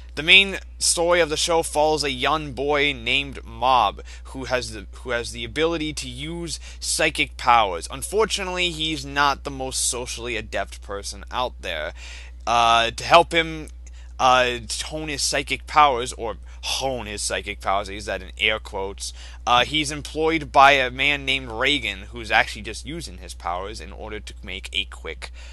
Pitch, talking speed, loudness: 130 Hz, 170 wpm, -21 LUFS